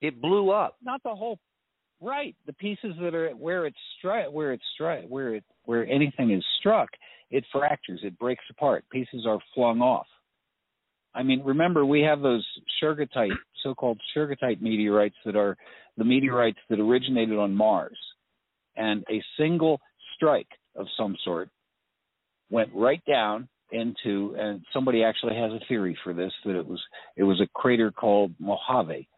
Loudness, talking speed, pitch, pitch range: -26 LUFS, 160 wpm, 125 Hz, 105-150 Hz